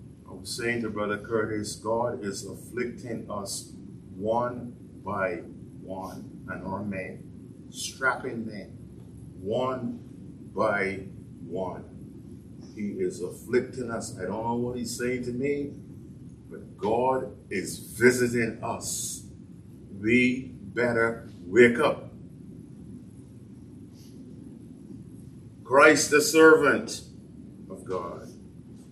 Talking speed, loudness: 95 wpm, -27 LUFS